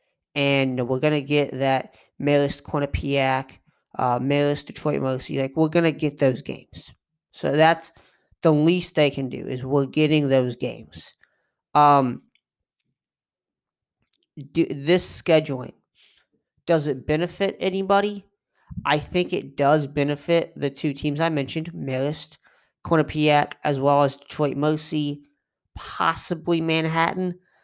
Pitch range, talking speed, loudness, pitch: 140-160 Hz, 120 wpm, -23 LUFS, 150 Hz